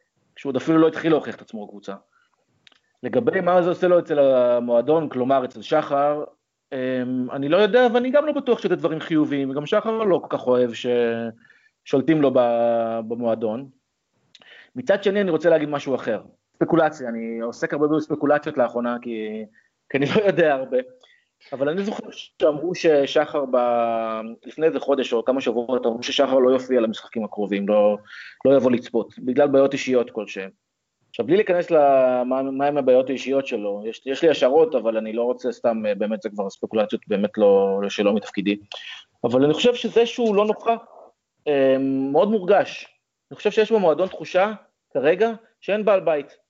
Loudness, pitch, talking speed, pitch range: -21 LUFS, 135 Hz, 160 wpm, 120-170 Hz